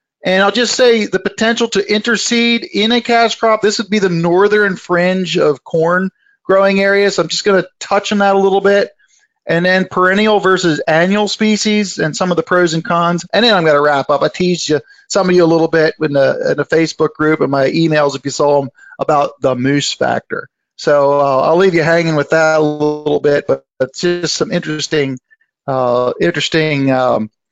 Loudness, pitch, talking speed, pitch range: -13 LUFS, 175 Hz, 215 wpm, 150-200 Hz